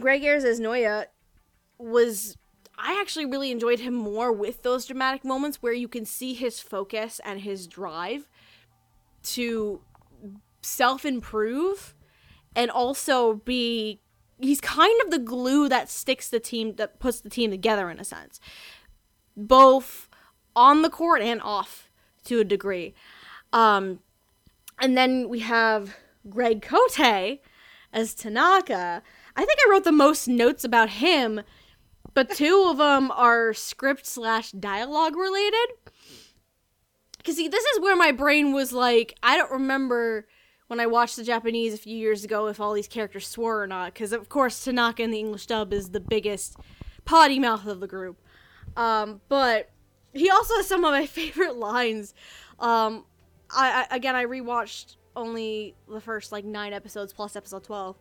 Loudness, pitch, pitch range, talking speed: -23 LUFS, 235 Hz, 215-270 Hz, 155 wpm